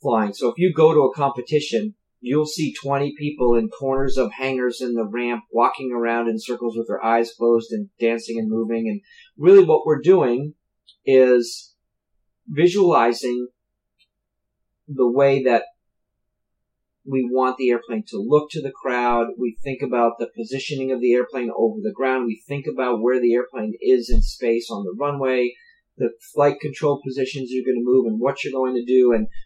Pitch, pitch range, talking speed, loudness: 125 Hz, 115-145 Hz, 180 wpm, -20 LUFS